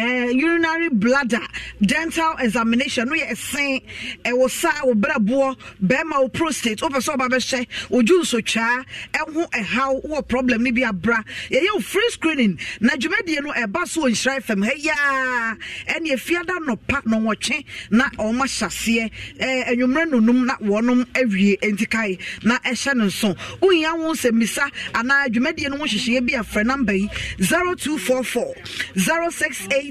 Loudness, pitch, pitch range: -20 LUFS, 255 Hz, 225-285 Hz